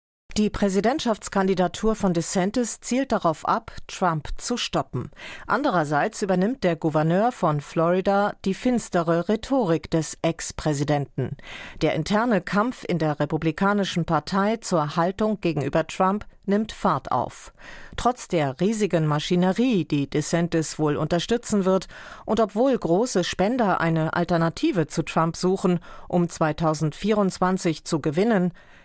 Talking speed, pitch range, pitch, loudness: 120 wpm, 165-205 Hz, 180 Hz, -24 LUFS